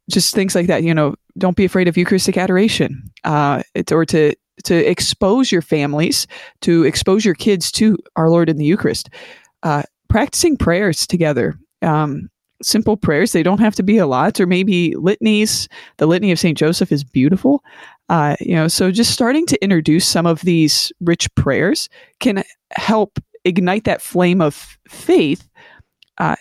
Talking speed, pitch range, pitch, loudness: 170 wpm, 160-215 Hz, 185 Hz, -16 LUFS